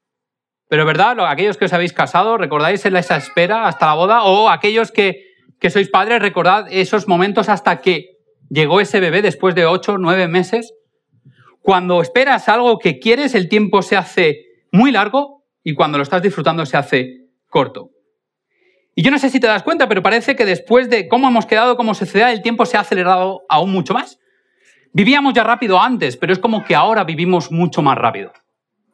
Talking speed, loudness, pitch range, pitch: 185 wpm, -14 LUFS, 175-230 Hz, 195 Hz